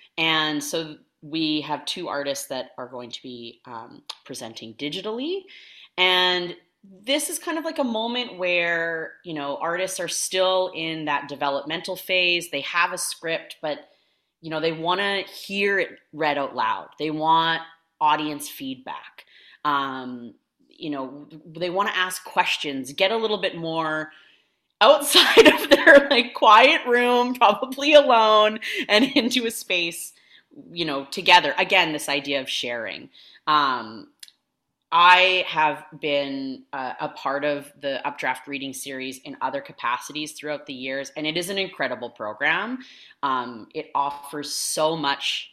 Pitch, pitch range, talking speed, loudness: 165 Hz, 145-195 Hz, 150 wpm, -21 LUFS